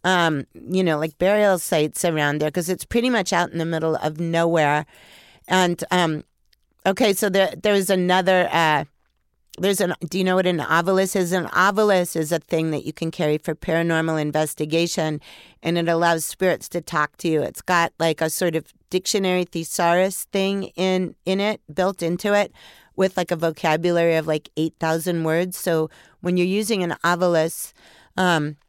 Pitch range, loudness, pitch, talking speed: 160-185 Hz, -21 LUFS, 170 Hz, 180 wpm